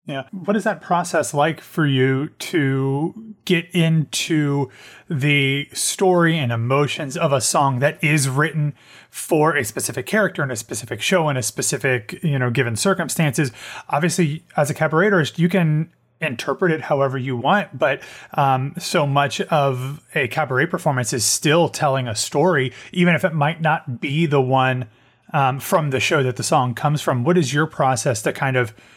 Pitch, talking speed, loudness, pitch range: 145 Hz, 175 wpm, -20 LUFS, 135-165 Hz